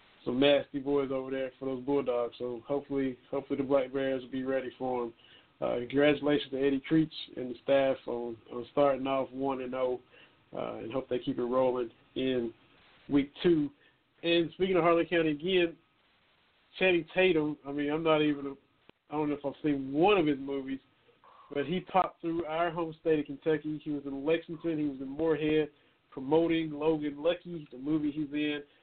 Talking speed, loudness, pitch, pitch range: 190 wpm, -31 LUFS, 140 Hz, 135-155 Hz